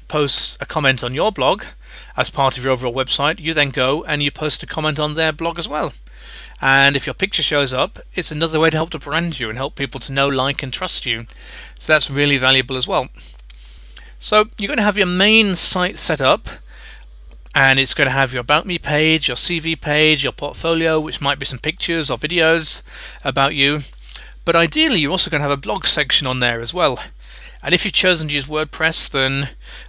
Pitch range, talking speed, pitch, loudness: 135-160 Hz, 220 wpm, 145 Hz, -16 LUFS